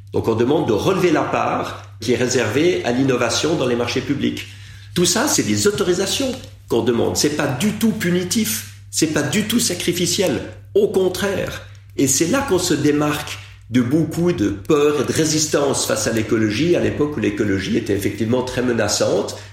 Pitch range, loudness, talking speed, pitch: 110-175 Hz, -19 LUFS, 185 wpm, 135 Hz